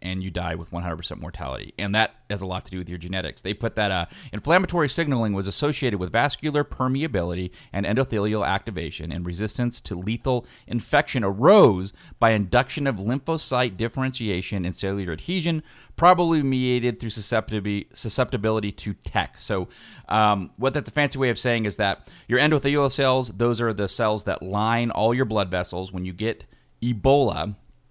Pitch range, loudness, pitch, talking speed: 95-130 Hz, -23 LUFS, 110 Hz, 170 wpm